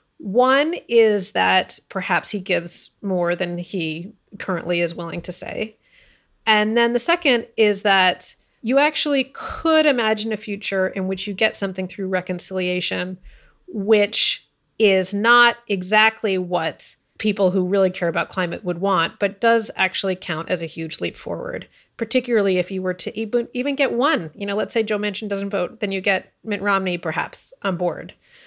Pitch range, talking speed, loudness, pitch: 185-225 Hz, 165 wpm, -20 LUFS, 200 Hz